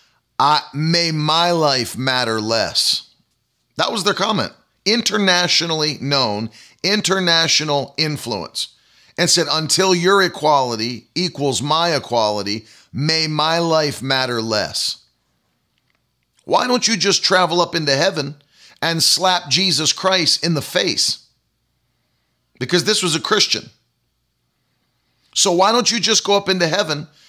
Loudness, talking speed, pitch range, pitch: -17 LUFS, 125 wpm, 140-180 Hz, 160 Hz